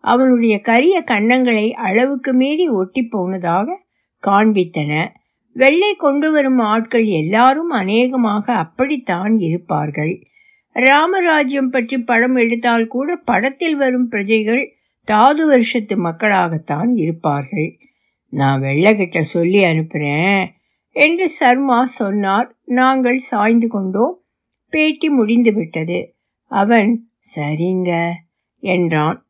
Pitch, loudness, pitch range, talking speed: 230 Hz, -15 LUFS, 185-260 Hz, 90 wpm